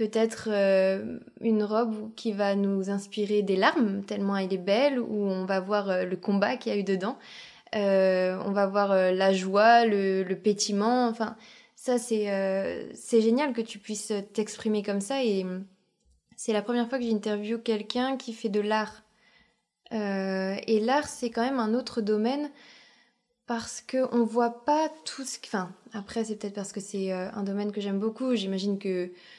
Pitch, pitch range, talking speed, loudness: 215 Hz, 200-235 Hz, 185 wpm, -28 LUFS